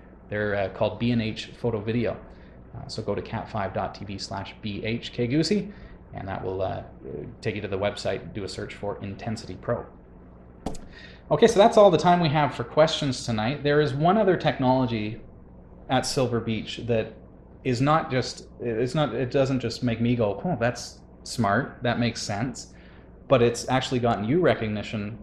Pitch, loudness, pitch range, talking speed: 115 Hz, -25 LUFS, 100-130 Hz, 170 wpm